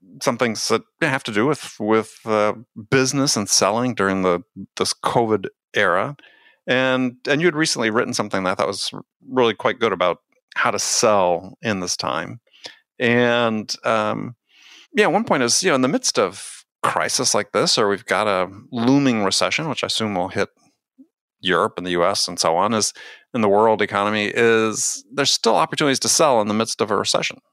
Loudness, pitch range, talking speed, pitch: -19 LUFS, 105-140 Hz, 190 wpm, 120 Hz